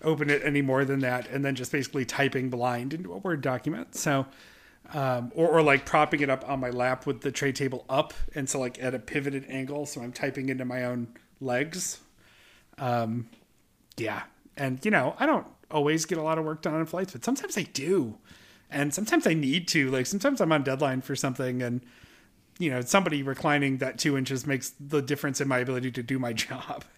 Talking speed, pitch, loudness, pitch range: 215 wpm, 140 Hz, -28 LUFS, 130-150 Hz